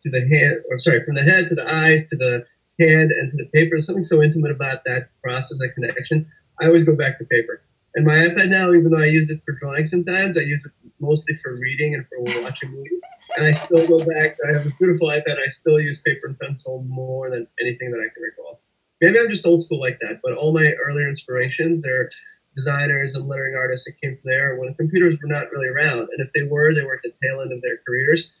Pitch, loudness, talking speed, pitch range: 150 Hz, -19 LUFS, 240 wpm, 130-160 Hz